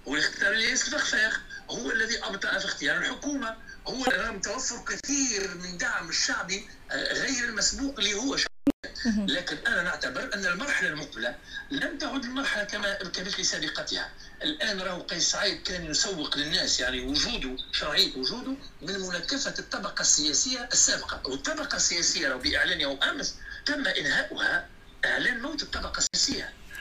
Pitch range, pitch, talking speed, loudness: 200-275 Hz, 240 Hz, 135 wpm, -27 LUFS